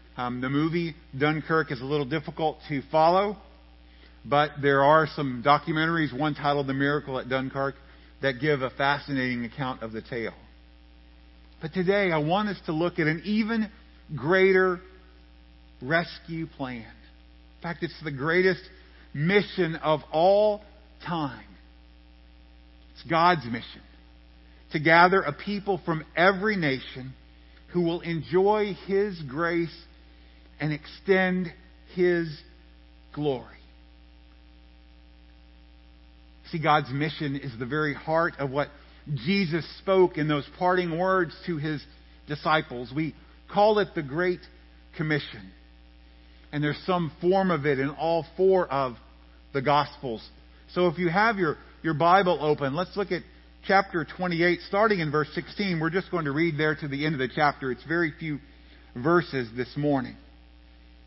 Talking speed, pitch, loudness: 140 wpm, 145 Hz, -26 LUFS